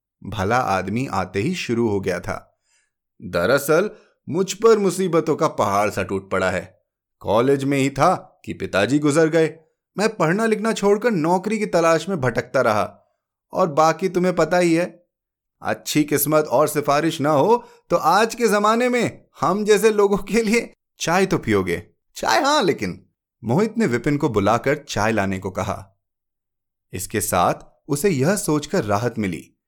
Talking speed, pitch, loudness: 160 wpm, 150 Hz, -20 LUFS